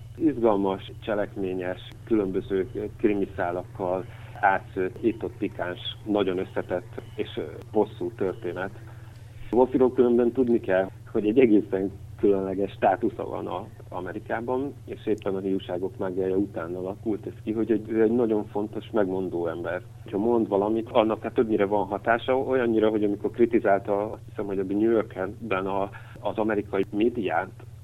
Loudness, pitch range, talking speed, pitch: -26 LUFS, 95-115 Hz, 130 wpm, 105 Hz